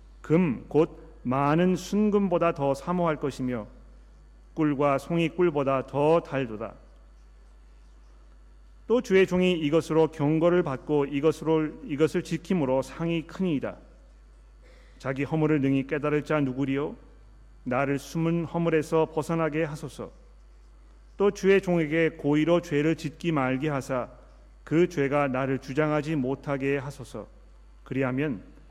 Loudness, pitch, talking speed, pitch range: -26 LUFS, 145 Hz, 255 characters per minute, 130-165 Hz